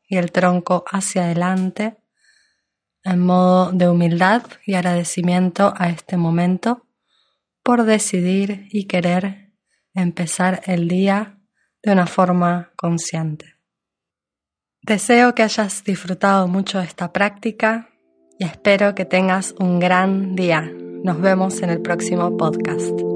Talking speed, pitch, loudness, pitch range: 120 wpm, 185 Hz, -18 LUFS, 175-200 Hz